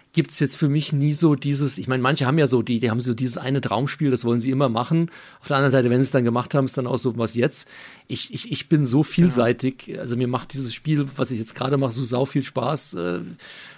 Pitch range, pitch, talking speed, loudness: 125-145 Hz, 135 Hz, 270 wpm, -21 LUFS